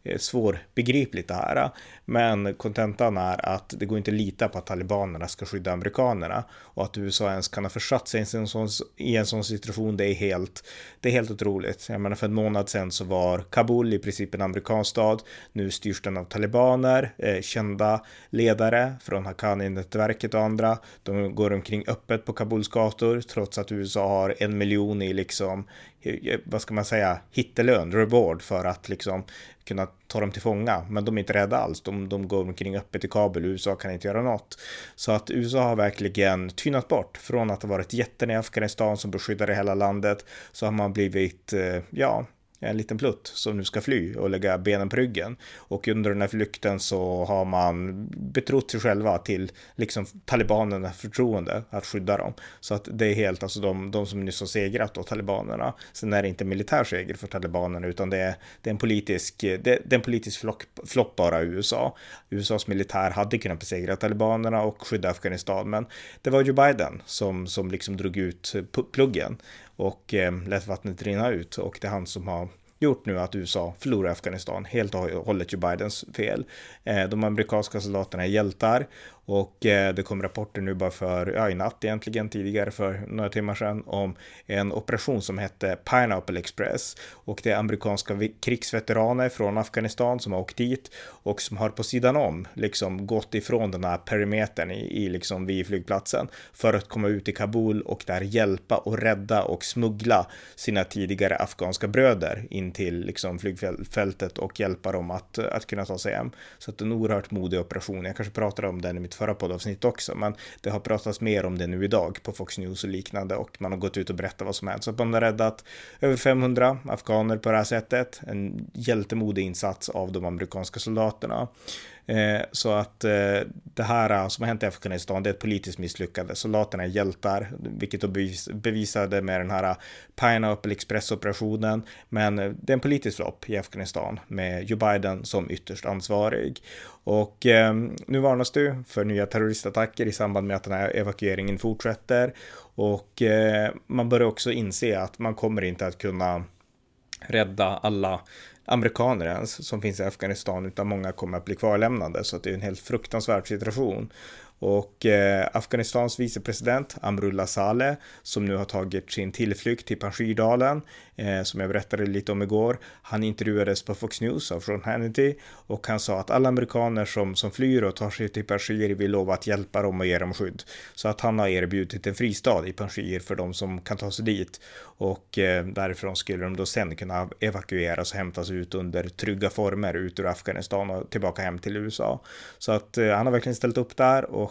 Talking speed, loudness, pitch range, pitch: 185 wpm, -27 LUFS, 95-110 Hz, 105 Hz